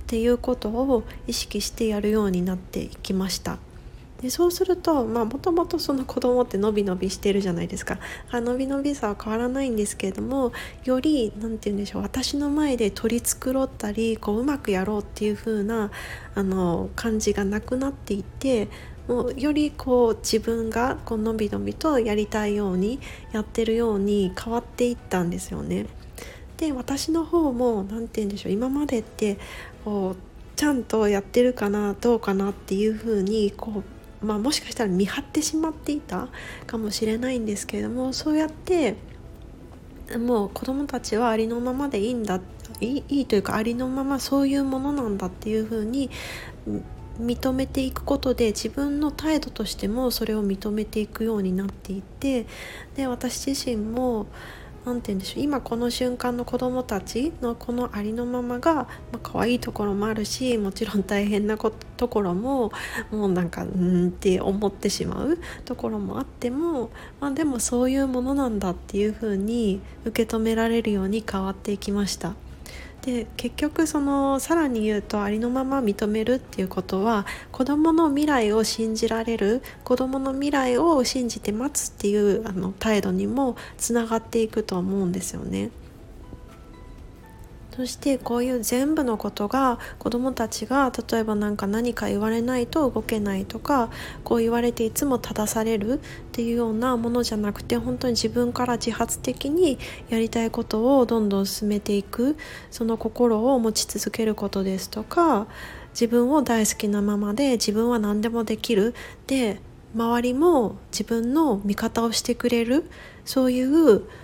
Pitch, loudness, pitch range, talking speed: 230 Hz, -25 LUFS, 210-255 Hz, 345 characters per minute